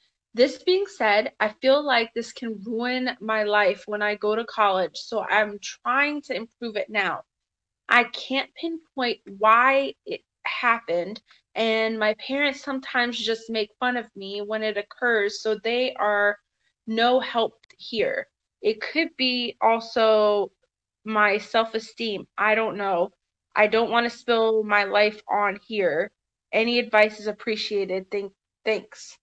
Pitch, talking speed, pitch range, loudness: 225 Hz, 145 wpm, 210-245 Hz, -24 LUFS